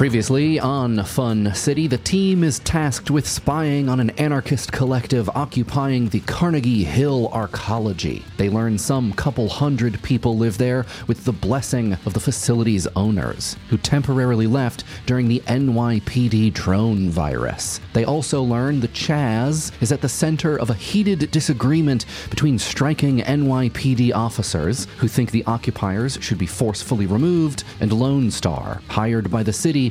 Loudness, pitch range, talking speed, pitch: -20 LUFS, 110-140 Hz, 150 wpm, 120 Hz